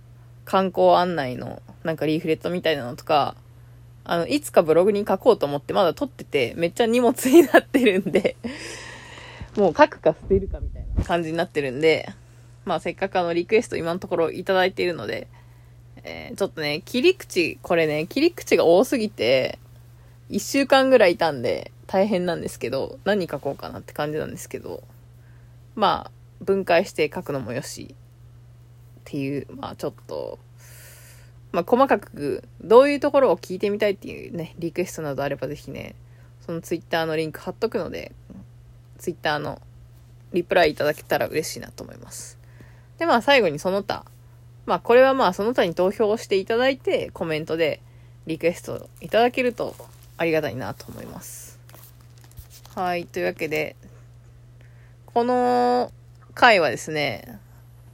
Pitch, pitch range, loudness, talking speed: 155 Hz, 120-190 Hz, -22 LUFS, 345 characters per minute